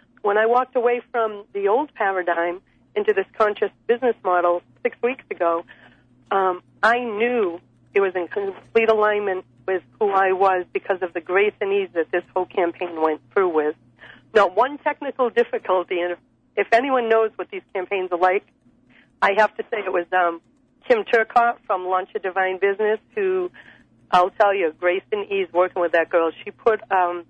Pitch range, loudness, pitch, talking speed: 180-220 Hz, -21 LUFS, 195 Hz, 180 wpm